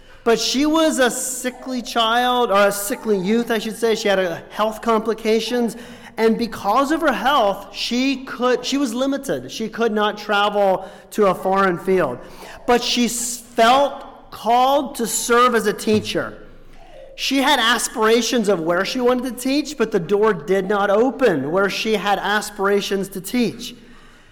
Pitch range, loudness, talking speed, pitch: 205-250 Hz, -19 LUFS, 160 wpm, 230 Hz